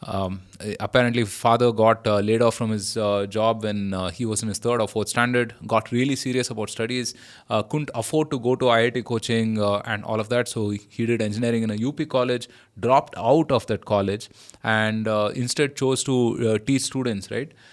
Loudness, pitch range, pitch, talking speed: -23 LUFS, 105-125 Hz, 115 Hz, 205 wpm